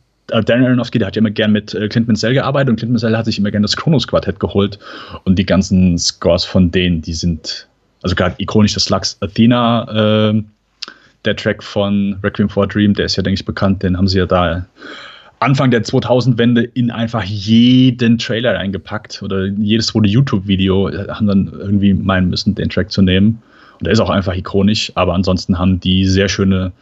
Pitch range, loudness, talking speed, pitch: 95-115 Hz, -14 LUFS, 200 wpm, 105 Hz